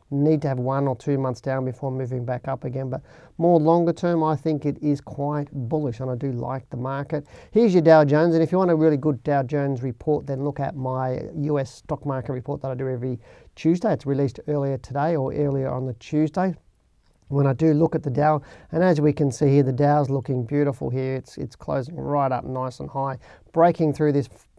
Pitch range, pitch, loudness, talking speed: 130-155 Hz, 140 Hz, -23 LUFS, 230 wpm